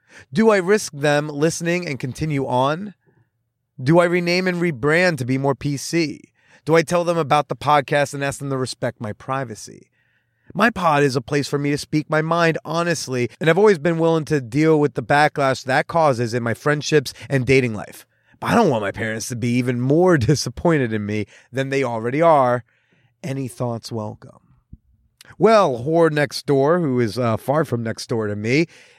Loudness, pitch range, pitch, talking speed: -19 LUFS, 125-165 Hz, 140 Hz, 195 wpm